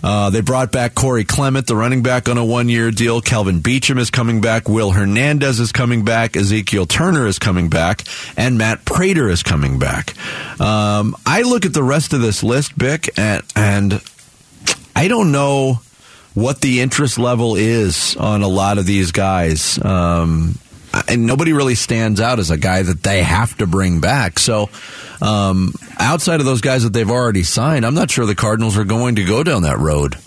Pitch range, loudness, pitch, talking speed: 100-125 Hz, -15 LUFS, 115 Hz, 195 wpm